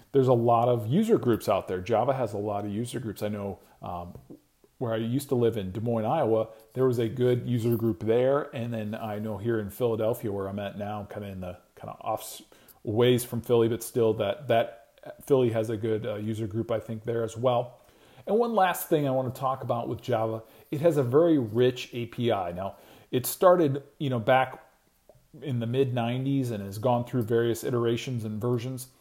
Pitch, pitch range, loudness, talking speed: 120 Hz, 110-130 Hz, -27 LUFS, 220 wpm